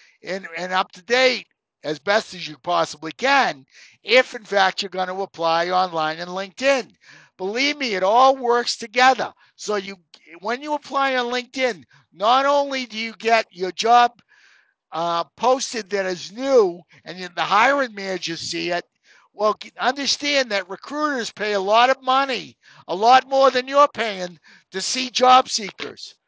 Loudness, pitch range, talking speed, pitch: -20 LUFS, 180-255 Hz, 160 wpm, 215 Hz